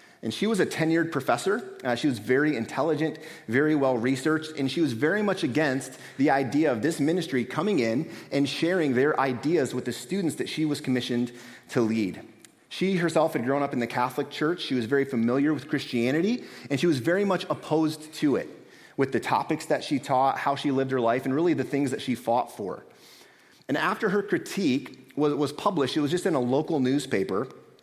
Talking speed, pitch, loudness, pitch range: 205 wpm, 145 Hz, -26 LUFS, 130-160 Hz